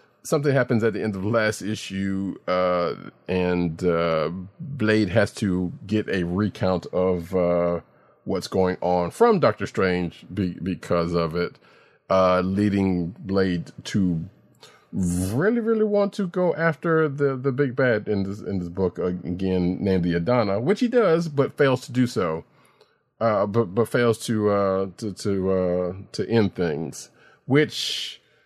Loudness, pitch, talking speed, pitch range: -23 LUFS, 95 Hz, 160 wpm, 90-120 Hz